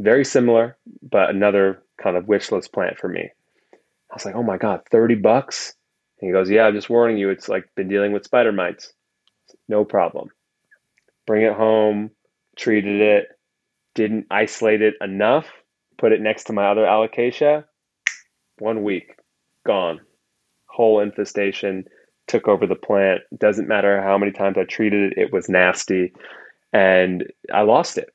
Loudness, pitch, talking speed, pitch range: -19 LUFS, 105 Hz, 160 wpm, 100-110 Hz